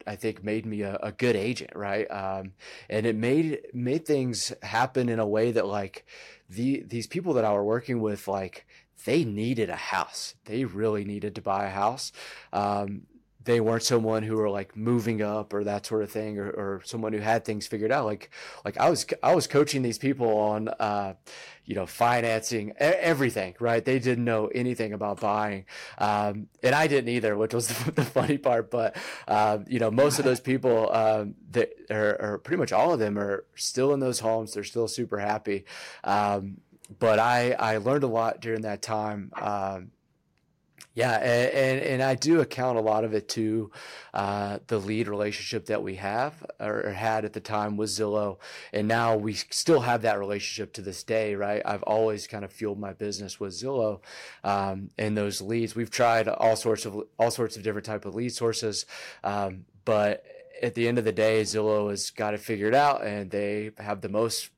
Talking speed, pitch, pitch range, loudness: 200 wpm, 110 Hz, 105-120 Hz, -27 LUFS